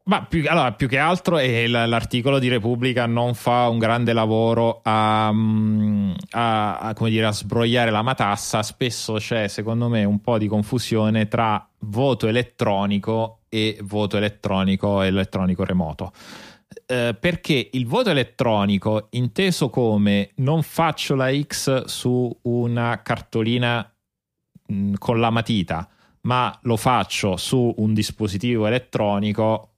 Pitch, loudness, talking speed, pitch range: 115 Hz, -21 LUFS, 135 wpm, 105-125 Hz